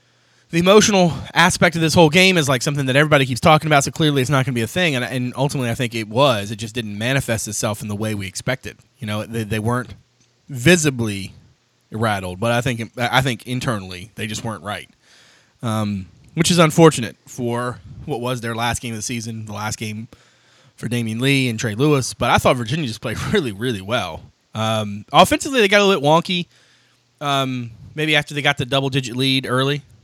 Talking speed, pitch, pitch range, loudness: 210 wpm, 125 Hz, 115-145 Hz, -18 LUFS